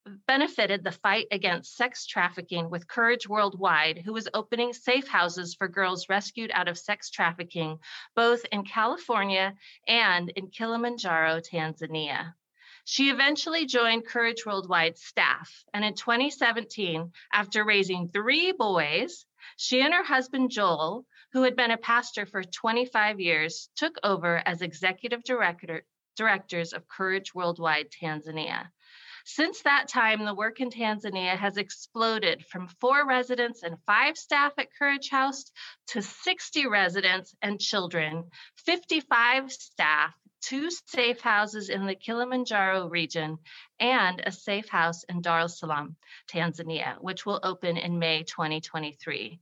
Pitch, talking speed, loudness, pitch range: 205 Hz, 135 wpm, -27 LUFS, 175-240 Hz